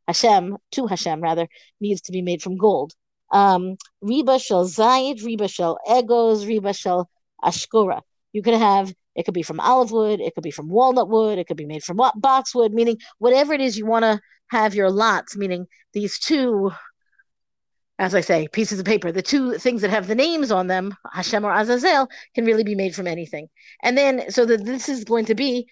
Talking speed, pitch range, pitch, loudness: 200 wpm, 185-245 Hz, 215 Hz, -20 LUFS